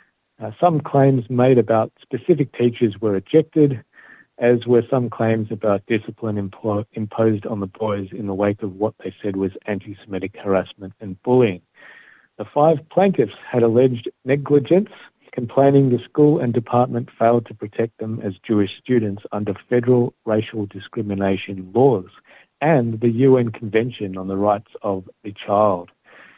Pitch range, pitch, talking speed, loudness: 100-125 Hz, 115 Hz, 150 wpm, -20 LUFS